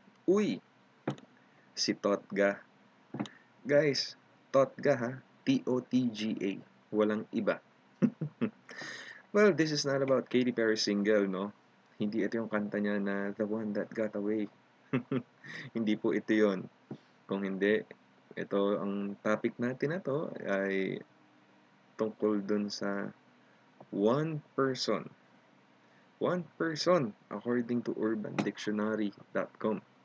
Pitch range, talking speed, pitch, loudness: 100-130 Hz, 105 wpm, 110 Hz, -33 LUFS